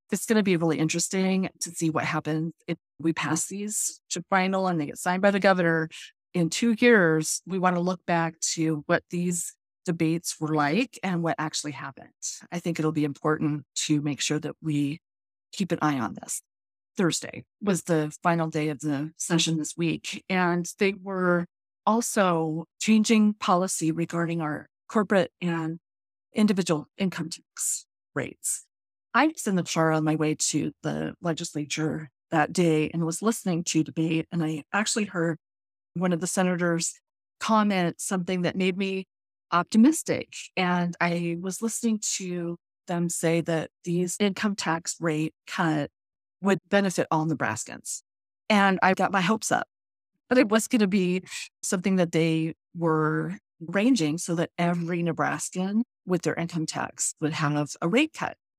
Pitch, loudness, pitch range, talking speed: 170 Hz, -26 LUFS, 155-190 Hz, 165 wpm